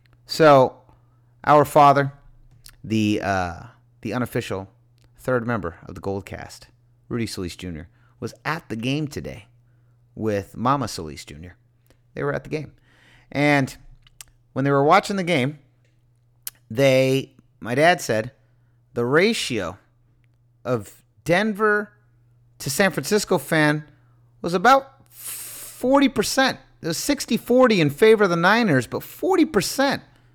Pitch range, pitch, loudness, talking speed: 120-150 Hz, 125 Hz, -21 LUFS, 125 wpm